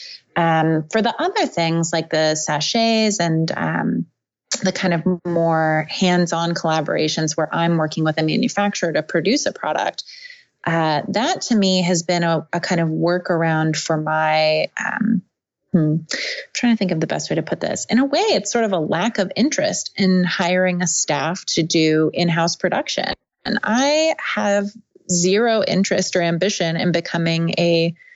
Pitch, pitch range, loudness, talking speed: 175 Hz, 165-205 Hz, -19 LUFS, 170 wpm